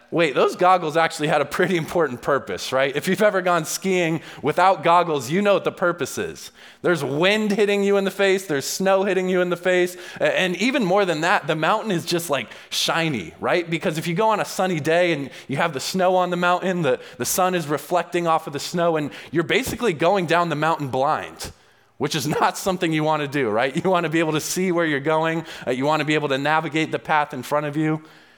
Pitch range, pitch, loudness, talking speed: 155-185 Hz, 170 Hz, -21 LUFS, 240 wpm